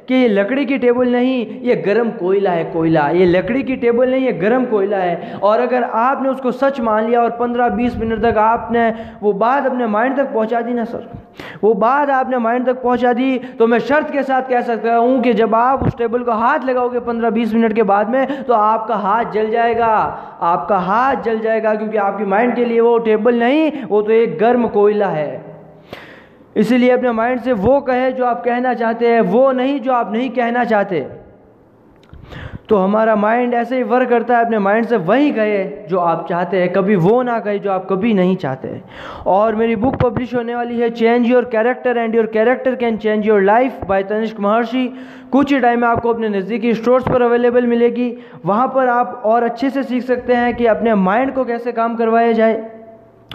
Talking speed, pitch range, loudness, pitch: 210 wpm, 220-245 Hz, -15 LUFS, 235 Hz